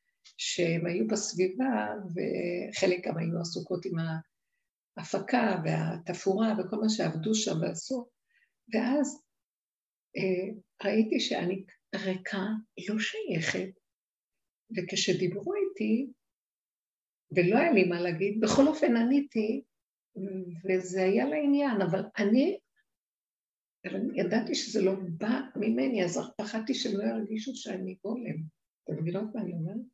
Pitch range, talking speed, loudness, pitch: 185-235 Hz, 110 wpm, -30 LUFS, 205 Hz